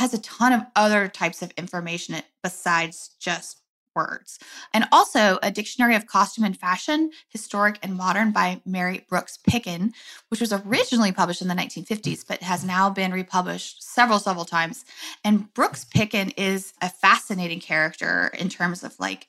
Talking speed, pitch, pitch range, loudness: 160 wpm, 195 Hz, 180-220 Hz, -23 LUFS